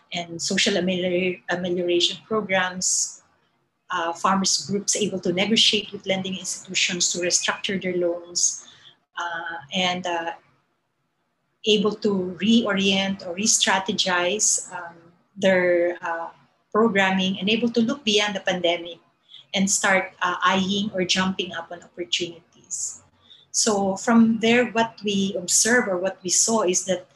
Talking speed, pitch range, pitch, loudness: 130 wpm, 175-200 Hz, 185 Hz, -22 LUFS